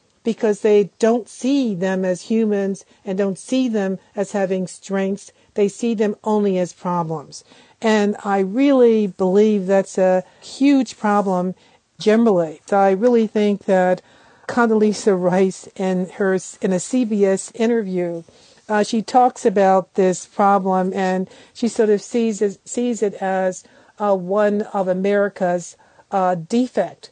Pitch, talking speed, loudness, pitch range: 200 Hz, 135 wpm, -19 LUFS, 190-225 Hz